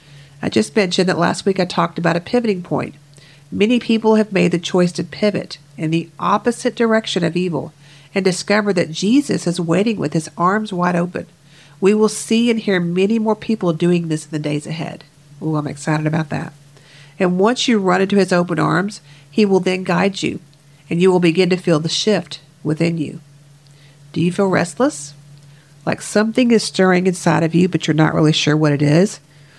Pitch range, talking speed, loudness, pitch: 150-195 Hz, 200 wpm, -17 LUFS, 175 Hz